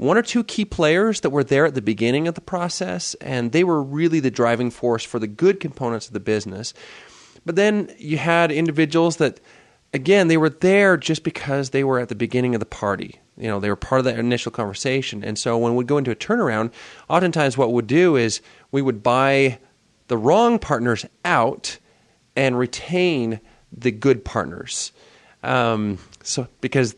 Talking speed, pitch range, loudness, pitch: 190 wpm, 115-165 Hz, -20 LUFS, 130 Hz